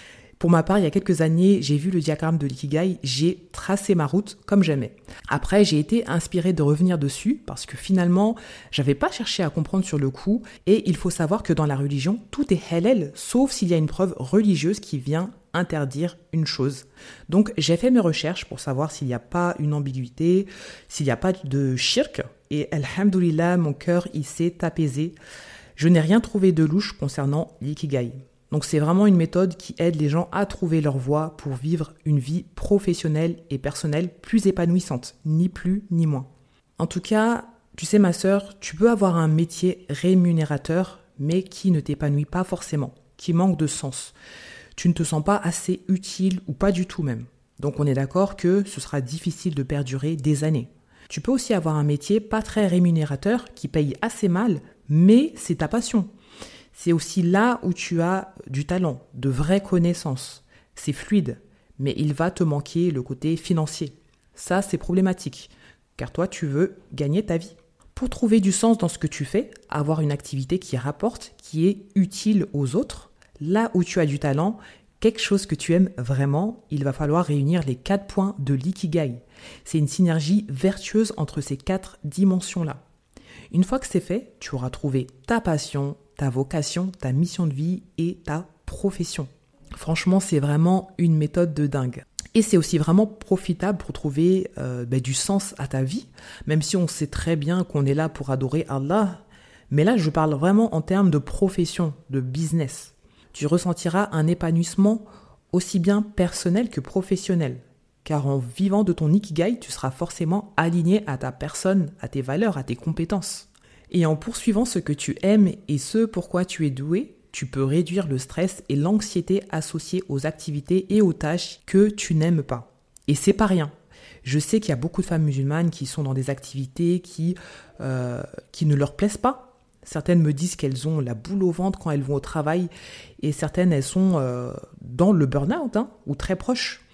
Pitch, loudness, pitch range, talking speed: 170 Hz, -23 LUFS, 145-190 Hz, 190 wpm